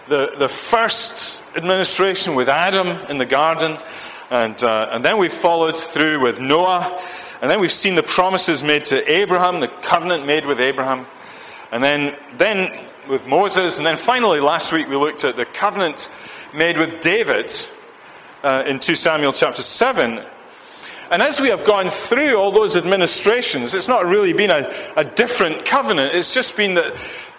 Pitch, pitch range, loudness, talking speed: 175 Hz, 150-215 Hz, -16 LUFS, 170 wpm